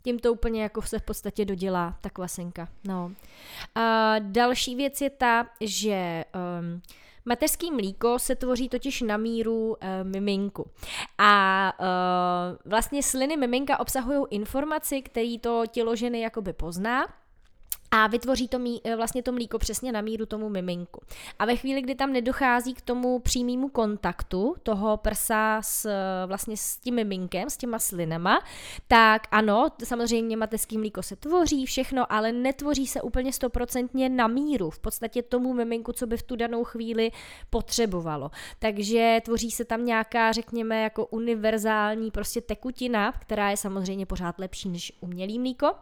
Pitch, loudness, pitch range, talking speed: 225 Hz, -27 LUFS, 205-245 Hz, 150 wpm